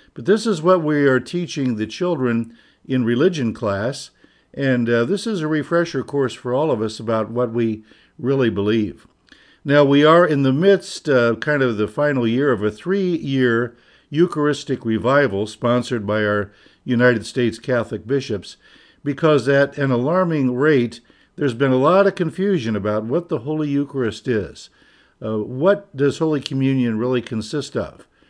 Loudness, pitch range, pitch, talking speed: -19 LUFS, 115-150 Hz, 130 Hz, 170 wpm